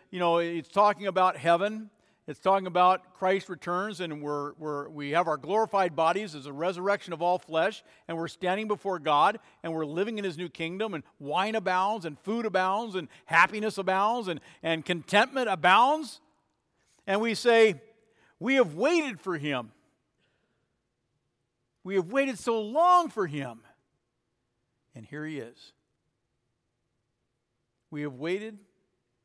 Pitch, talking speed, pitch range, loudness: 180 Hz, 150 wpm, 150-205 Hz, -27 LUFS